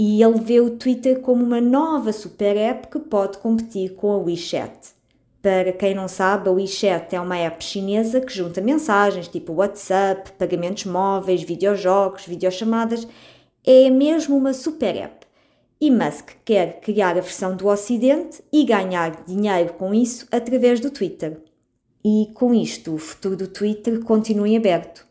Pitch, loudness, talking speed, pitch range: 205 Hz, -20 LUFS, 160 wpm, 185-235 Hz